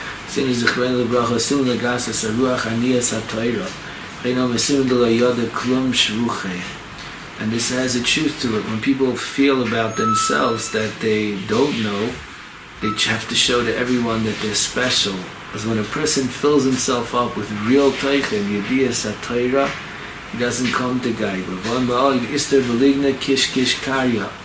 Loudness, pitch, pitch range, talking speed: -18 LUFS, 125 Hz, 110-130 Hz, 185 wpm